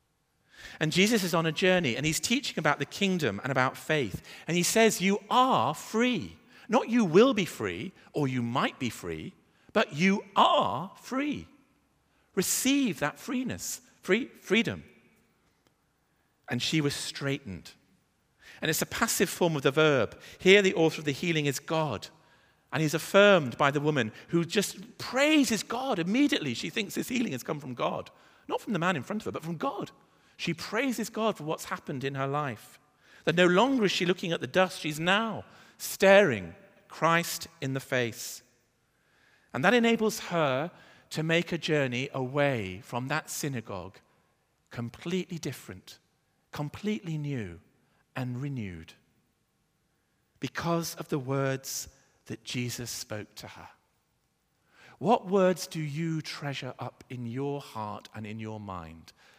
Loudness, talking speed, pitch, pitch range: -28 LUFS, 155 wpm, 155 Hz, 130-190 Hz